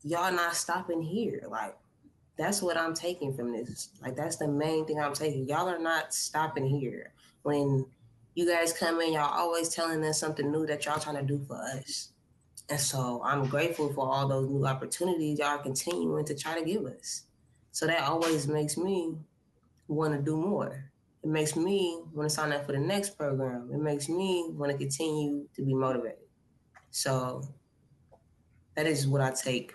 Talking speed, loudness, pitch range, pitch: 185 wpm, -31 LUFS, 140-165 Hz, 150 Hz